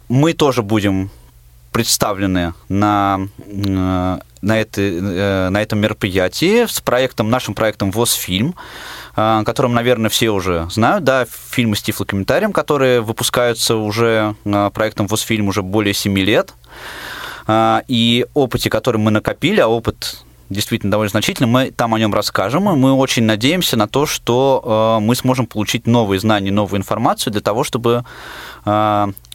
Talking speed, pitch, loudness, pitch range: 135 wpm, 110 Hz, -16 LUFS, 100-120 Hz